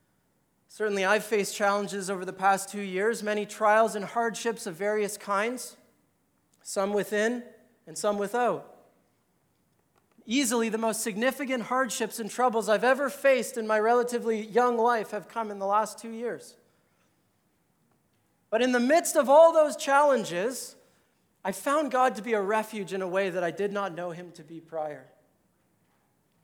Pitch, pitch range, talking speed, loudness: 220 Hz, 200-240 Hz, 160 wpm, -27 LUFS